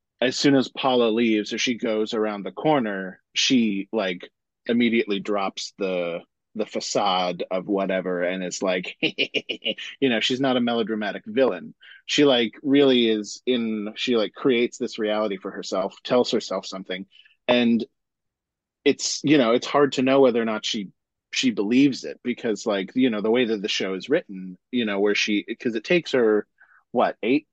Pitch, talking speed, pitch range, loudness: 110 Hz, 175 wpm, 100-125 Hz, -23 LUFS